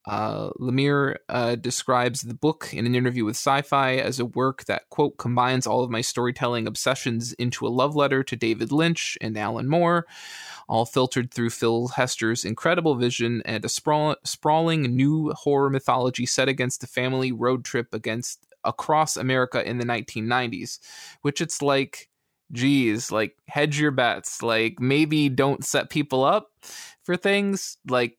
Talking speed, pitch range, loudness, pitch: 160 wpm, 120-145 Hz, -24 LUFS, 130 Hz